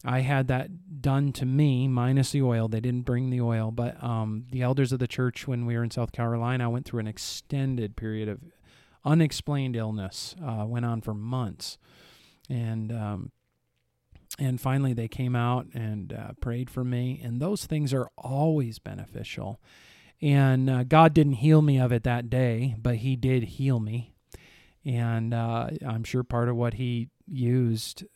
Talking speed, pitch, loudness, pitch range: 175 wpm, 125 Hz, -27 LUFS, 115-130 Hz